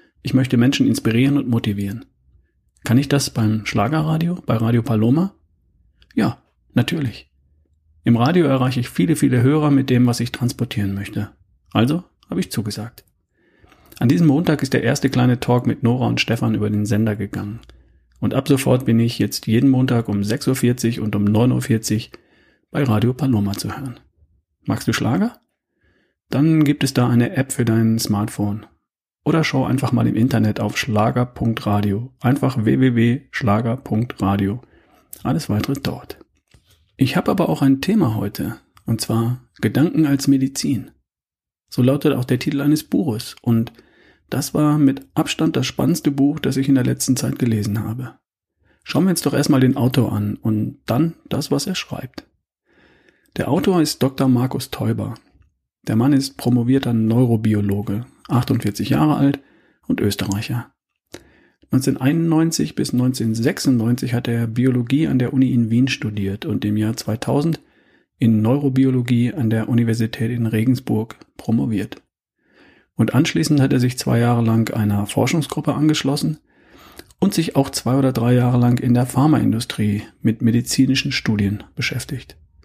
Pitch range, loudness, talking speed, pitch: 110-135 Hz, -19 LUFS, 150 wpm, 120 Hz